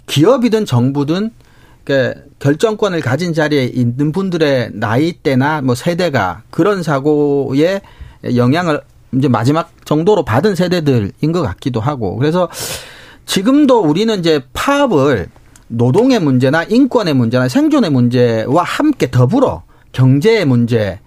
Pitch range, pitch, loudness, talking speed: 125-180 Hz, 145 Hz, -14 LUFS, 285 characters per minute